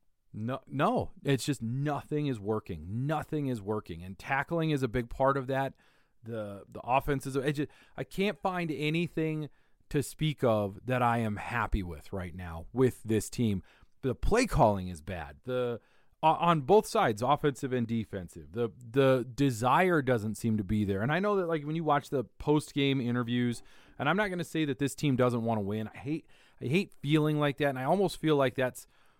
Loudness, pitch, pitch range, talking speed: -31 LUFS, 130 Hz, 110-150 Hz, 200 wpm